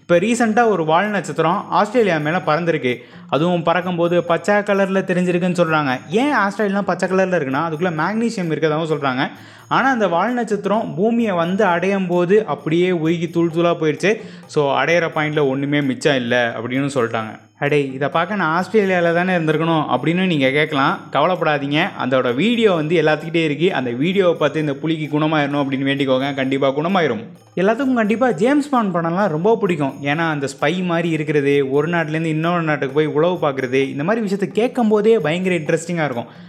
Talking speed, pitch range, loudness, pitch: 160 wpm, 150-195 Hz, -18 LUFS, 170 Hz